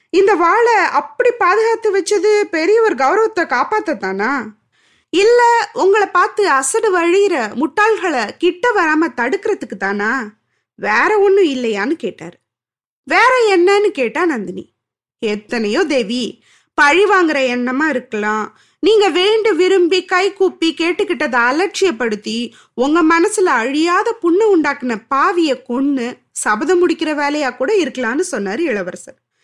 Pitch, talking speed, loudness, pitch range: 345 Hz, 110 wpm, -15 LUFS, 260-400 Hz